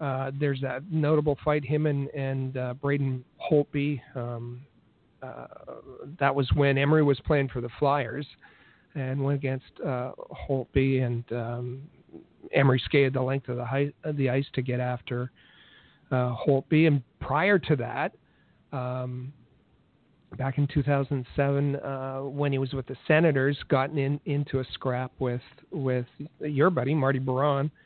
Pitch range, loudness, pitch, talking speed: 130-145 Hz, -27 LUFS, 135 Hz, 150 wpm